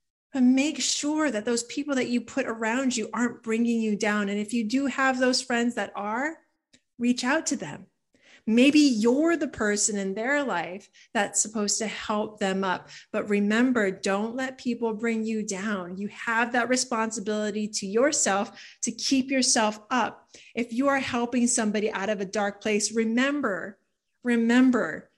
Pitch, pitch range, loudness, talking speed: 230 Hz, 210-260 Hz, -26 LUFS, 170 wpm